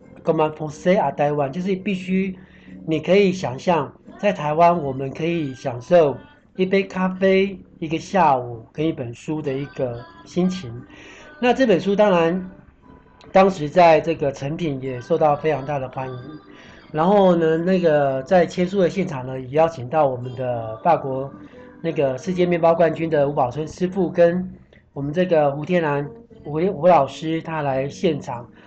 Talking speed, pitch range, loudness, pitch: 225 characters per minute, 140-180 Hz, -20 LUFS, 160 Hz